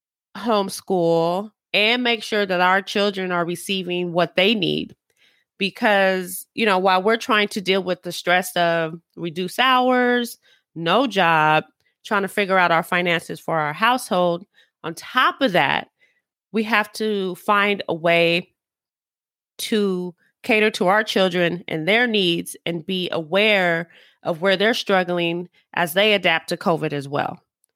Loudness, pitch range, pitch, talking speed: -20 LUFS, 175-215 Hz, 190 Hz, 150 wpm